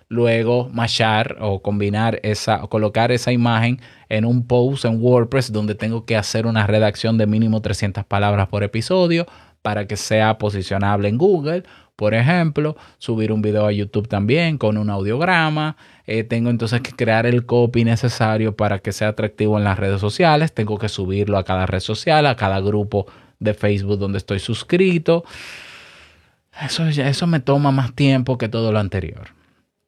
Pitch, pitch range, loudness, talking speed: 110 Hz, 105-125 Hz, -19 LUFS, 170 wpm